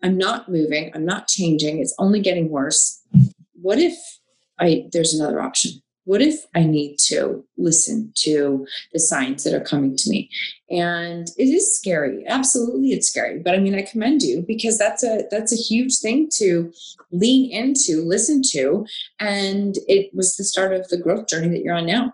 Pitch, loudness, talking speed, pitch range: 195 Hz, -19 LUFS, 185 wpm, 170-240 Hz